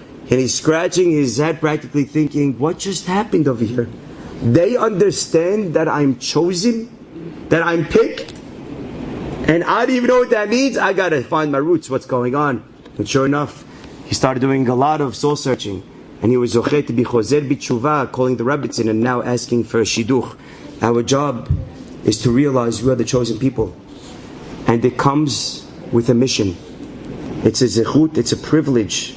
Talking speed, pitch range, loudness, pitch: 170 wpm, 120-155 Hz, -17 LUFS, 135 Hz